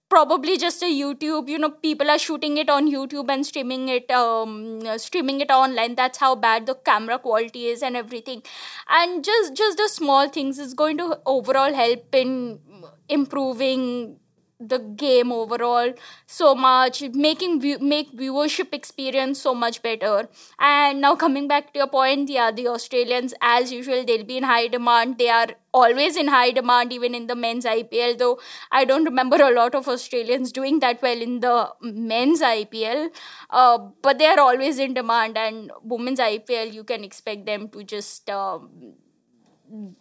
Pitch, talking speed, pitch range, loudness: 255 Hz, 170 wpm, 235-285 Hz, -21 LUFS